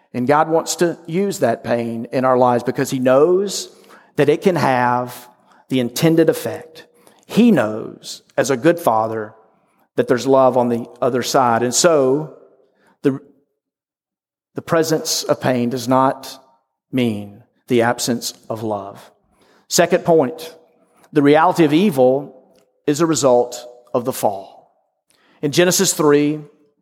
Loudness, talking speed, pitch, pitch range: -17 LUFS, 140 wpm, 135 Hz, 125-155 Hz